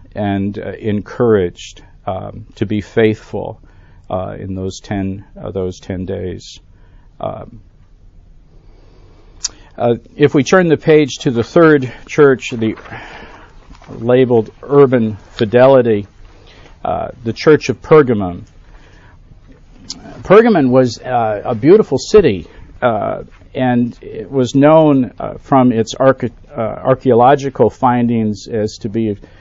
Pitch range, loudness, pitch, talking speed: 95-130 Hz, -14 LUFS, 110 Hz, 115 wpm